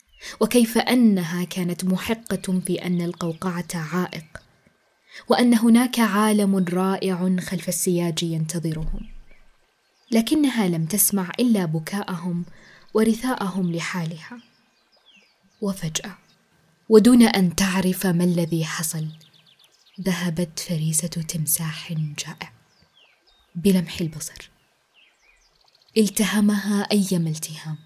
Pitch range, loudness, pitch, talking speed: 165-205 Hz, -22 LUFS, 180 Hz, 80 wpm